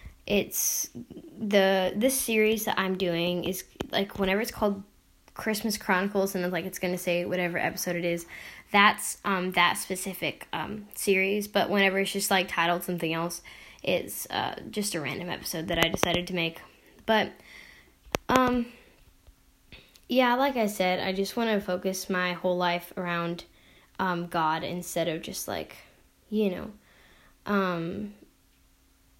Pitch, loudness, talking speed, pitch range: 185 Hz, -28 LUFS, 150 wpm, 175-205 Hz